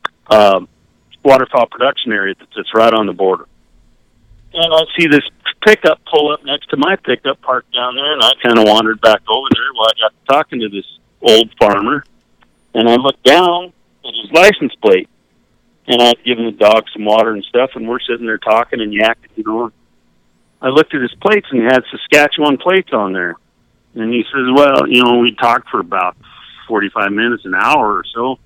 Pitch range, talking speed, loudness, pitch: 110-145 Hz, 200 wpm, -12 LUFS, 120 Hz